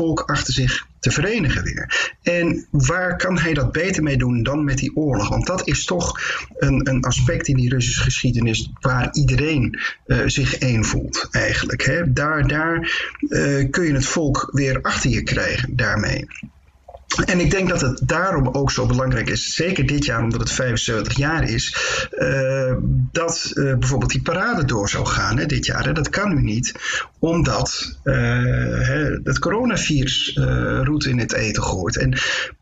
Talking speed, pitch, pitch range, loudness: 175 wpm, 135 Hz, 125-155 Hz, -20 LUFS